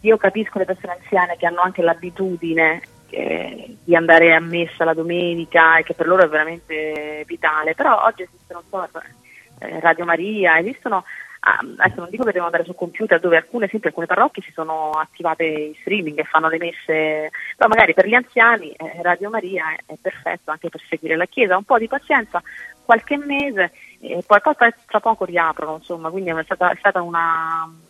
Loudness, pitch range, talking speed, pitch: -18 LUFS, 160-195 Hz, 195 wpm, 175 Hz